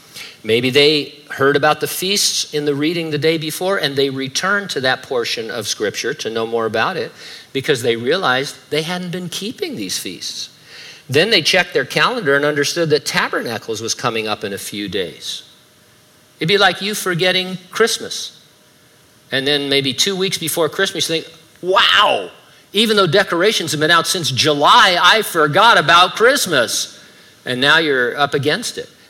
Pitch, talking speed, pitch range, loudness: 160 Hz, 175 wpm, 140-190 Hz, -16 LUFS